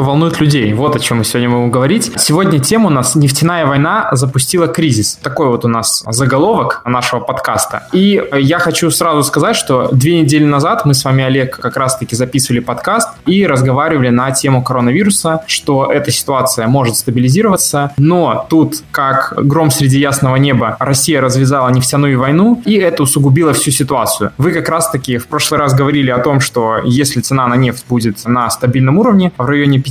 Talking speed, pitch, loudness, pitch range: 175 wpm, 140 Hz, -11 LUFS, 125-155 Hz